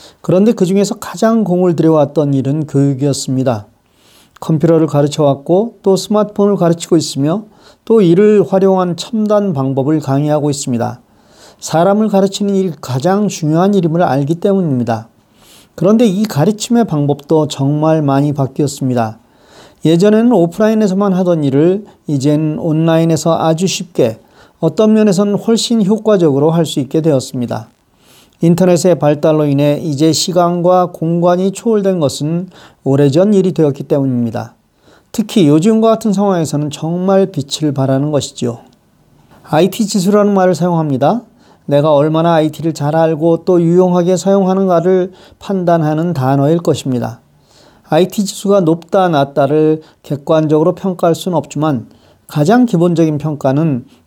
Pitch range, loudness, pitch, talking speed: 145-195 Hz, -13 LUFS, 165 Hz, 325 characters per minute